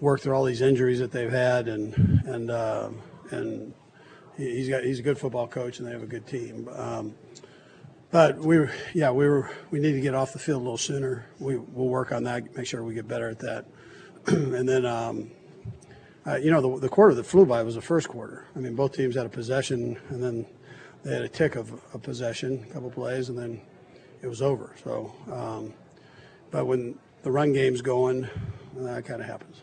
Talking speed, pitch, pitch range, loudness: 215 wpm, 130 Hz, 120-135 Hz, -27 LUFS